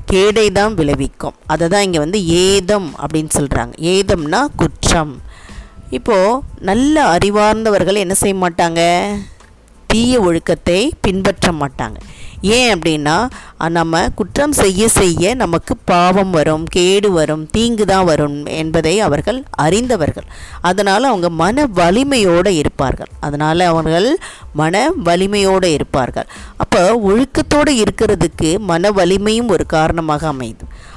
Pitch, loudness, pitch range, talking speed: 180 Hz, -14 LUFS, 160-205 Hz, 110 wpm